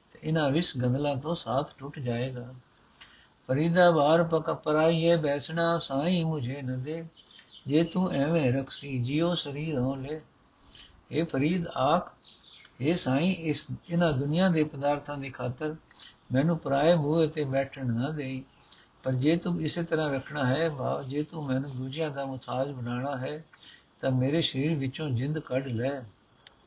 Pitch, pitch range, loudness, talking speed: 145 Hz, 130-160 Hz, -29 LUFS, 145 wpm